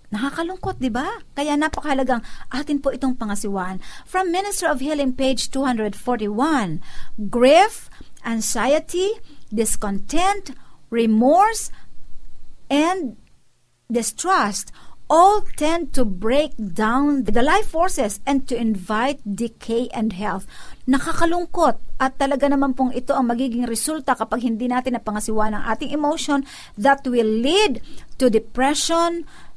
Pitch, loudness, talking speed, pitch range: 265 Hz, -21 LUFS, 115 wpm, 230-305 Hz